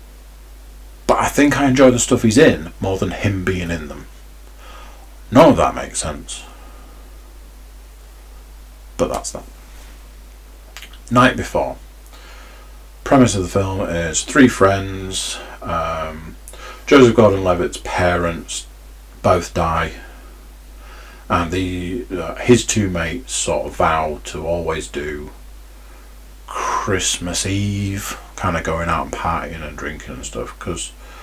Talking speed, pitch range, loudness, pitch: 120 wpm, 65-95 Hz, -18 LUFS, 85 Hz